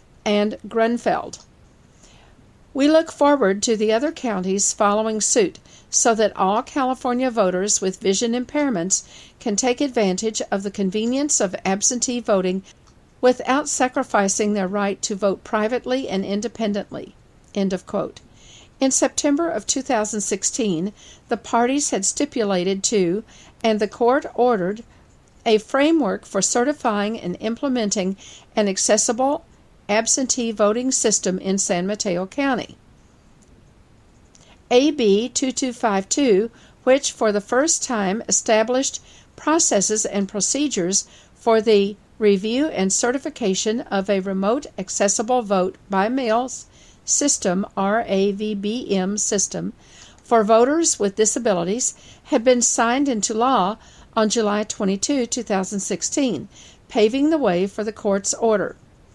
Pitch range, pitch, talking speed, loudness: 200-255 Hz, 220 Hz, 115 wpm, -20 LUFS